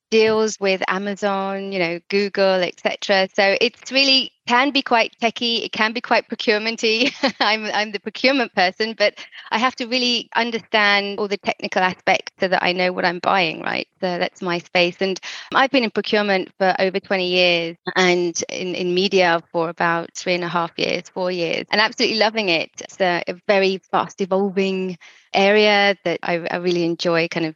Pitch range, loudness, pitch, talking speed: 180-220 Hz, -19 LUFS, 195 Hz, 190 wpm